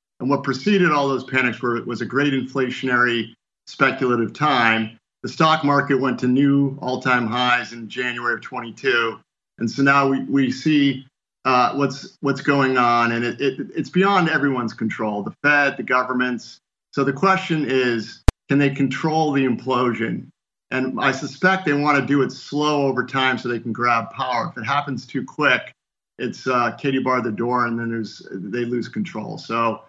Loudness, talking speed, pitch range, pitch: -20 LUFS, 180 wpm, 120-140 Hz, 130 Hz